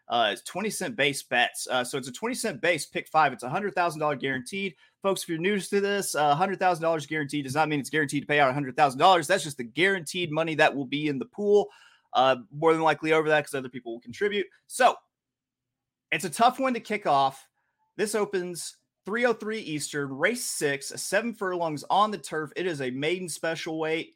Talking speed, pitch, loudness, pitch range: 230 wpm, 160 Hz, -26 LUFS, 140-195 Hz